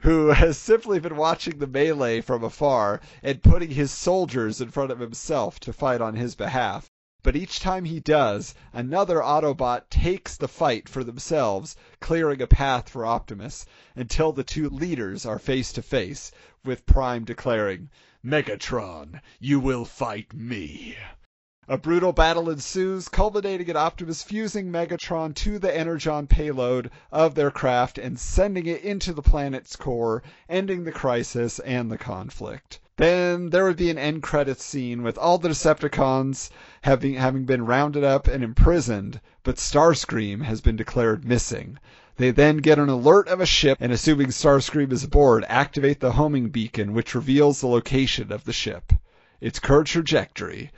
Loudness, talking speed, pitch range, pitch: -23 LUFS, 160 wpm, 125-160 Hz, 140 Hz